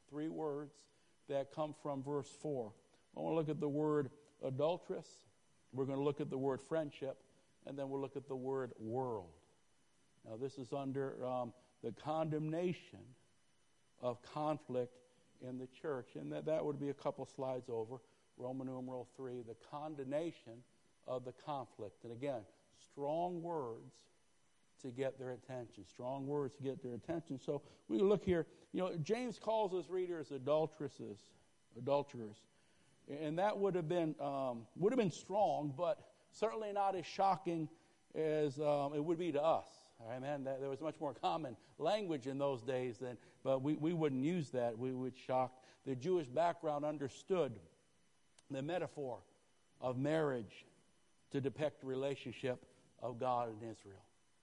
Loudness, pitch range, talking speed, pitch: -41 LUFS, 125-155 Hz, 160 wpm, 140 Hz